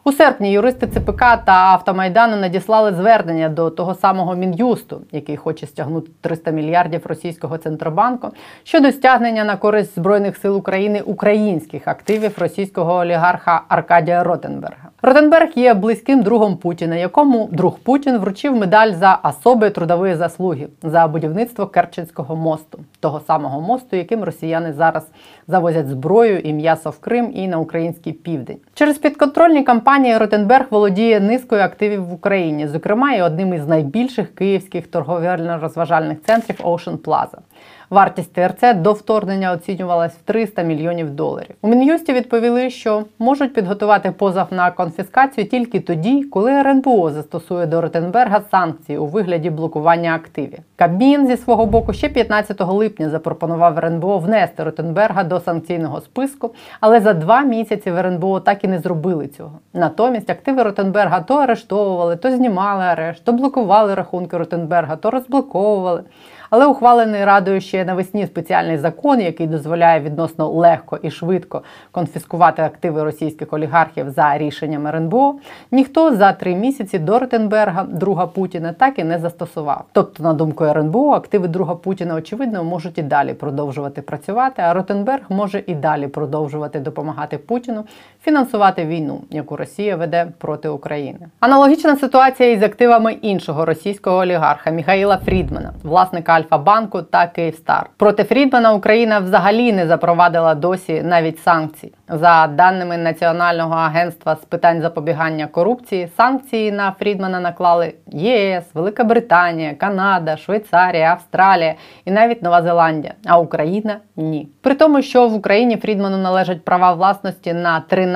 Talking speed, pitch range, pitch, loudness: 140 wpm, 165-215 Hz, 185 Hz, -16 LUFS